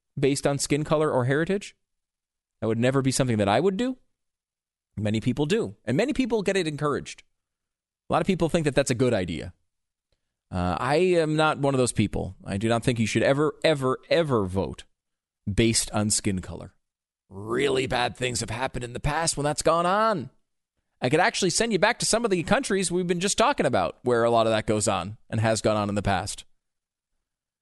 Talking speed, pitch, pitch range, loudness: 215 wpm, 125 Hz, 105-160 Hz, -25 LUFS